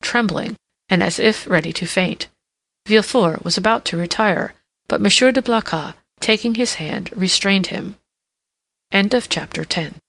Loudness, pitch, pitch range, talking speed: -18 LUFS, 205 Hz, 185-230 Hz, 135 wpm